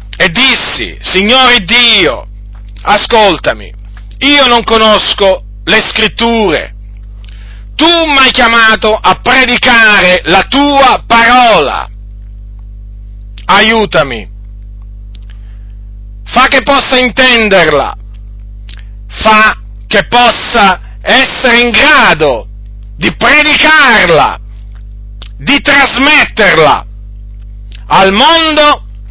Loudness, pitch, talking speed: -5 LUFS, 195 Hz, 75 wpm